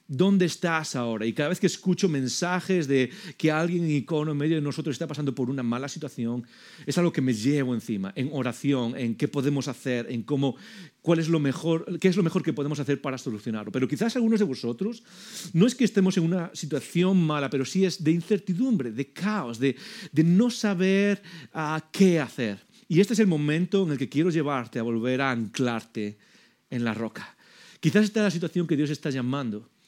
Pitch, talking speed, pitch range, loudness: 155 Hz, 210 wpm, 130-185 Hz, -26 LUFS